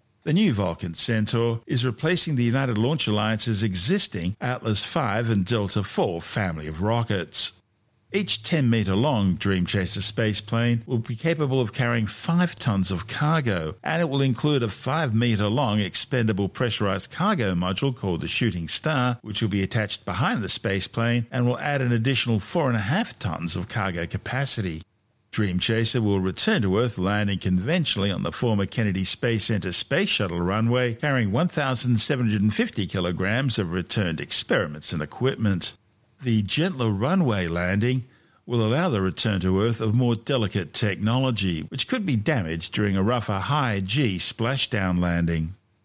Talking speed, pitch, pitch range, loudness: 155 wpm, 110 Hz, 95-125 Hz, -24 LUFS